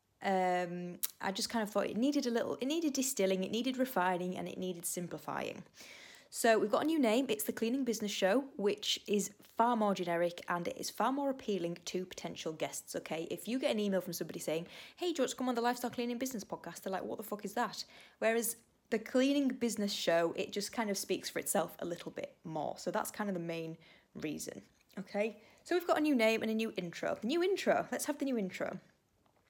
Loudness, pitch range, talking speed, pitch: -35 LUFS, 185-250 Hz, 225 wpm, 215 Hz